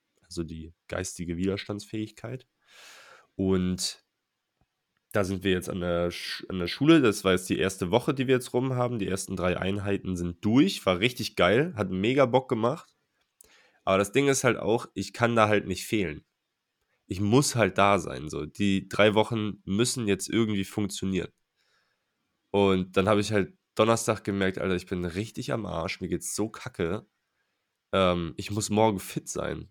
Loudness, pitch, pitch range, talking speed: -27 LUFS, 100 Hz, 95-110 Hz, 175 wpm